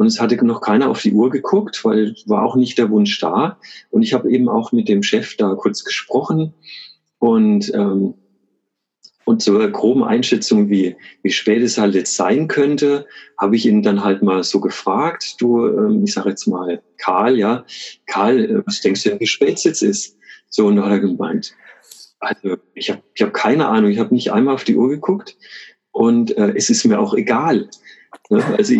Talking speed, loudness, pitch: 205 wpm, -16 LUFS, 125 Hz